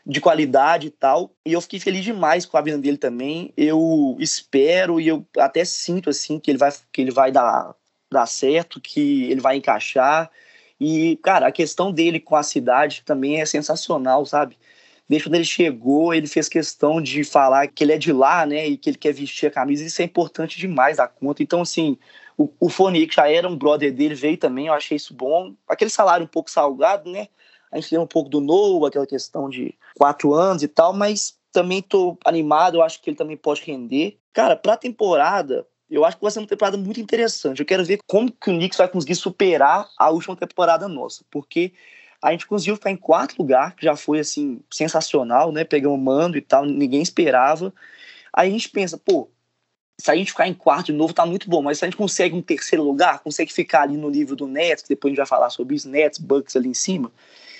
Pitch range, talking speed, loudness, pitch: 145-190 Hz, 220 wpm, -19 LUFS, 160 Hz